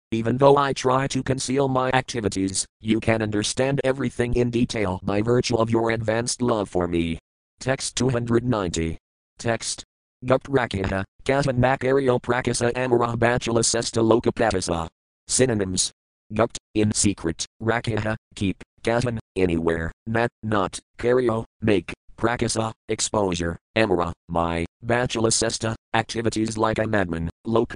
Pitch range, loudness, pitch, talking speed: 95-120 Hz, -23 LUFS, 115 Hz, 130 wpm